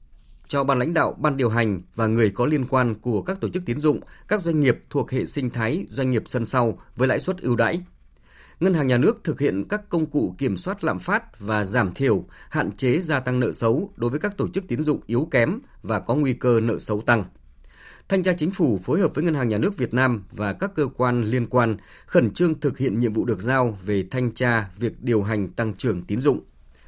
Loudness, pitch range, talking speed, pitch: -23 LUFS, 110-145 Hz, 245 wpm, 125 Hz